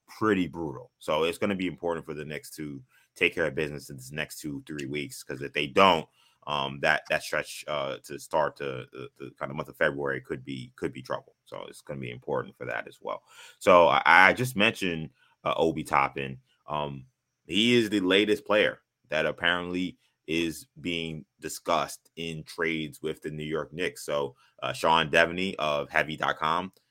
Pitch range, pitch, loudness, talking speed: 75-90 Hz, 80 Hz, -27 LUFS, 190 wpm